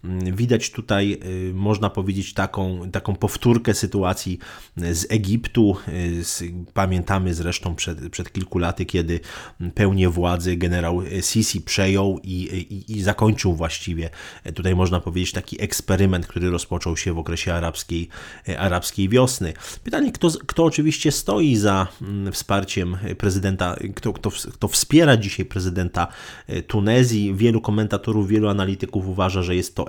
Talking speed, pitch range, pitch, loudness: 125 wpm, 90-105 Hz, 95 Hz, -22 LUFS